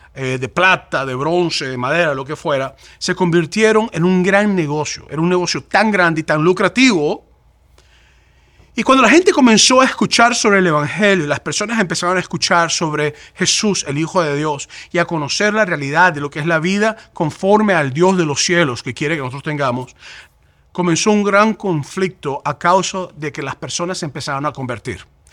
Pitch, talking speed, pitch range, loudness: 170 Hz, 185 wpm, 145-190 Hz, -15 LUFS